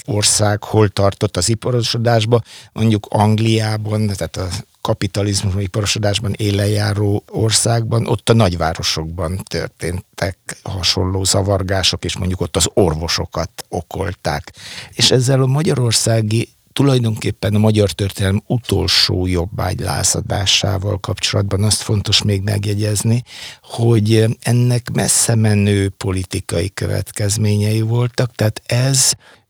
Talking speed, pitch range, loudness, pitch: 100 wpm, 100-115 Hz, -16 LUFS, 105 Hz